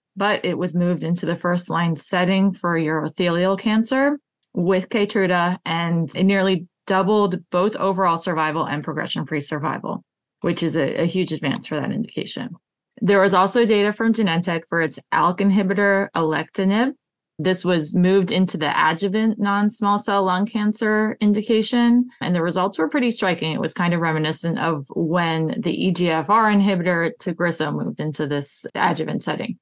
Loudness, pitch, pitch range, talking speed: -20 LUFS, 185 Hz, 165-205 Hz, 160 wpm